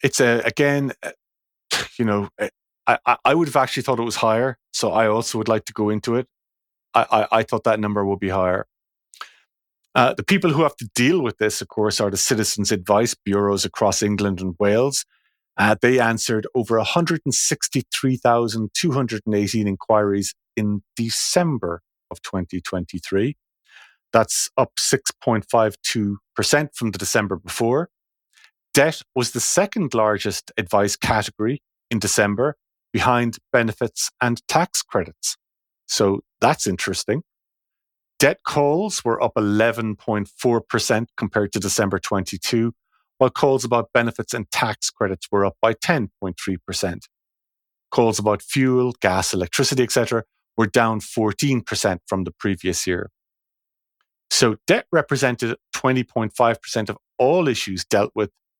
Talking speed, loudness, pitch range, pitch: 130 wpm, -21 LUFS, 100-125 Hz, 110 Hz